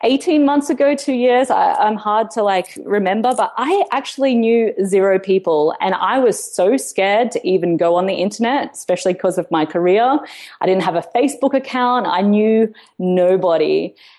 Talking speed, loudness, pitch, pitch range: 180 wpm, -16 LUFS, 215 Hz, 185-260 Hz